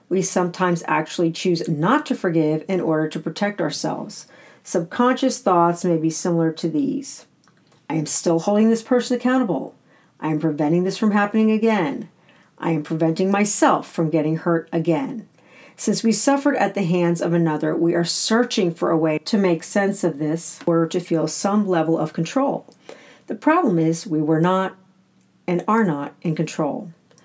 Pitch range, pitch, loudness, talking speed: 165-210 Hz, 180 Hz, -21 LUFS, 170 wpm